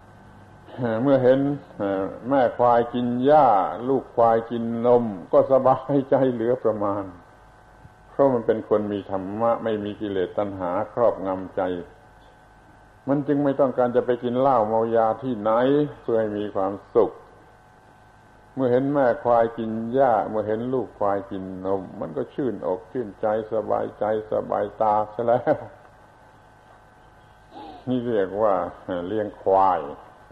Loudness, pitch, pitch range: -23 LUFS, 115 Hz, 105-125 Hz